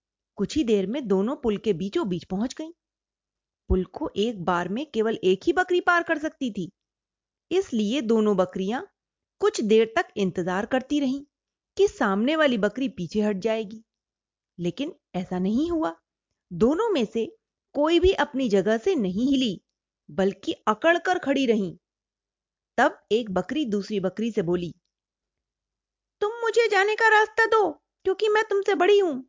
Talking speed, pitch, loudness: 155 wpm, 230 Hz, -24 LUFS